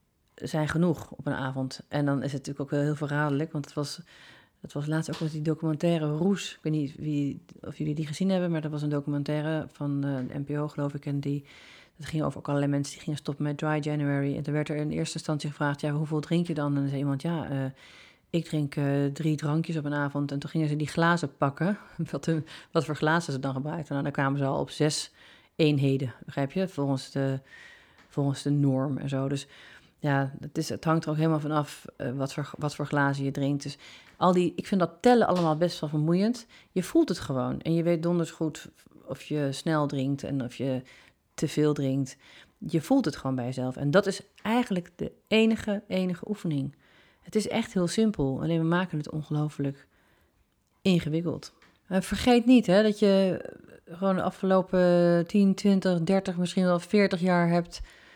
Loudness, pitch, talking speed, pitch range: -28 LUFS, 150 Hz, 215 wpm, 140-175 Hz